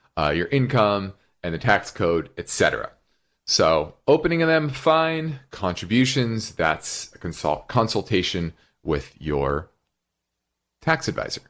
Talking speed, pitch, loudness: 115 wpm, 110 Hz, -23 LUFS